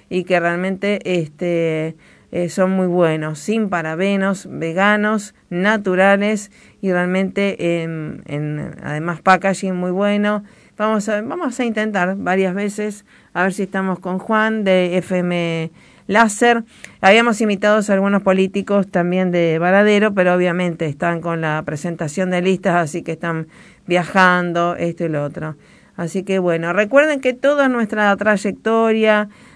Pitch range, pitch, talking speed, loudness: 175-210 Hz, 190 Hz, 140 wpm, -17 LUFS